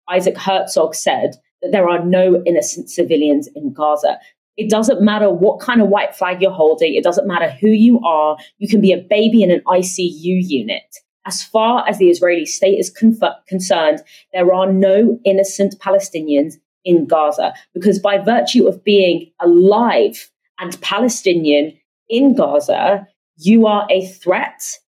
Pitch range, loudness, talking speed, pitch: 175-210 Hz, -15 LUFS, 160 wpm, 190 Hz